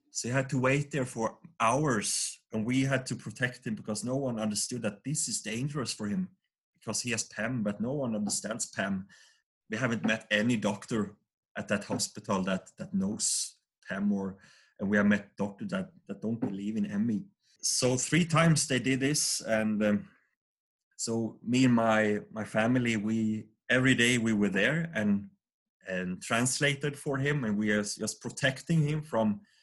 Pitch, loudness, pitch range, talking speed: 120 Hz, -30 LUFS, 105-145 Hz, 180 wpm